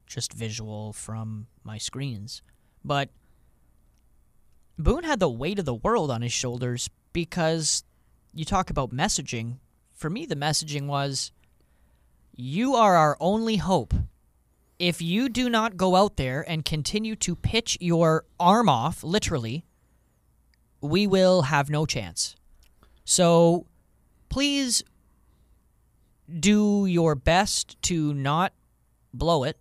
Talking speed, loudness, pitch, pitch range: 120 wpm, -25 LUFS, 145 Hz, 105-175 Hz